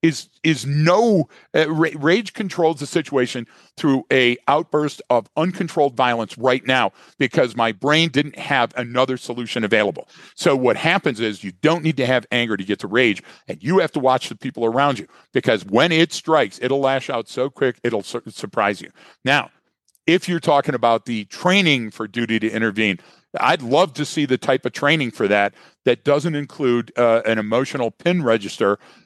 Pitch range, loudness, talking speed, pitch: 120-160 Hz, -19 LUFS, 185 wpm, 130 Hz